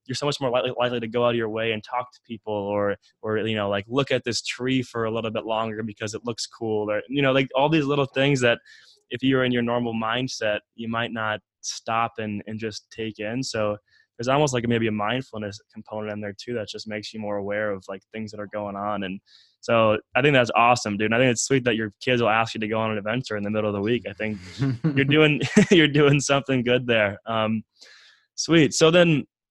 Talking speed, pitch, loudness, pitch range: 250 wpm, 115 Hz, -23 LUFS, 105-130 Hz